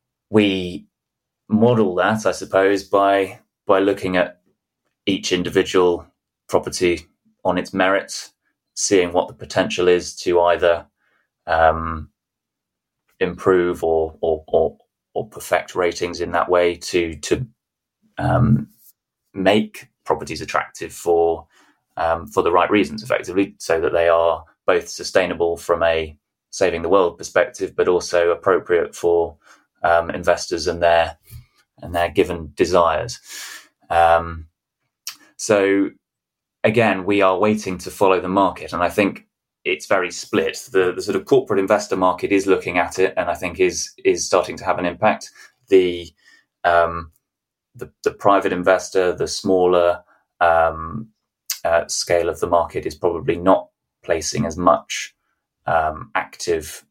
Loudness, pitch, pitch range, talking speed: -19 LUFS, 90 Hz, 85-105 Hz, 135 wpm